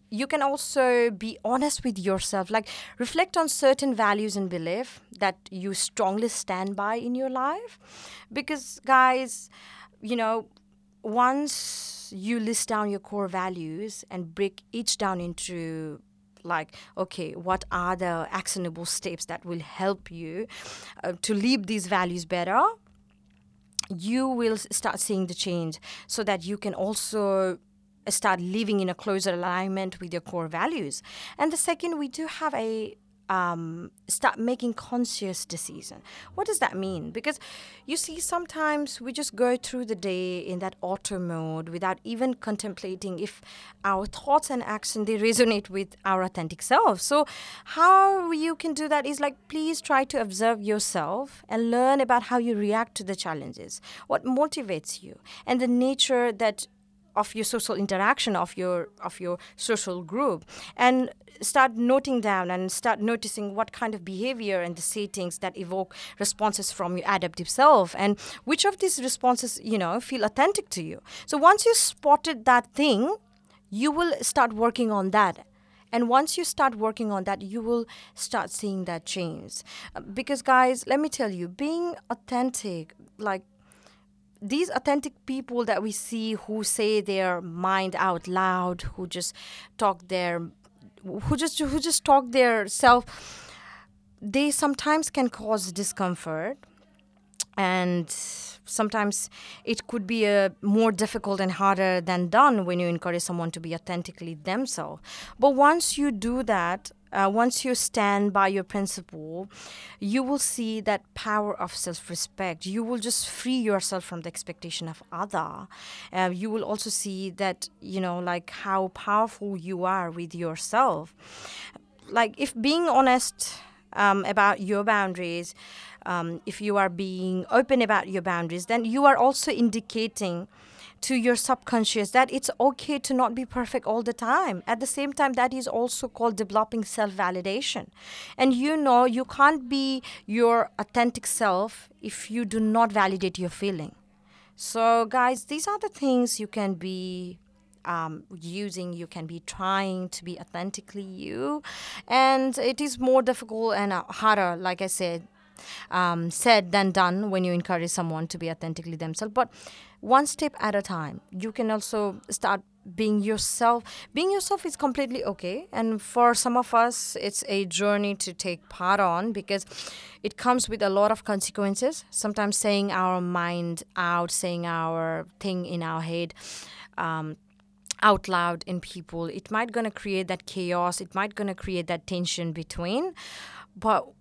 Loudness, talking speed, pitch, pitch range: -26 LUFS, 160 wpm, 210 Hz, 185-245 Hz